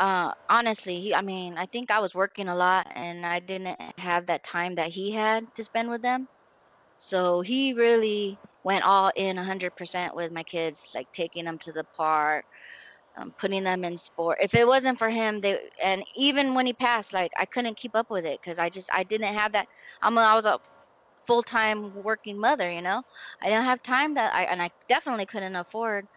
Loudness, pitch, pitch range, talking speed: -26 LUFS, 195 Hz, 180-225 Hz, 210 wpm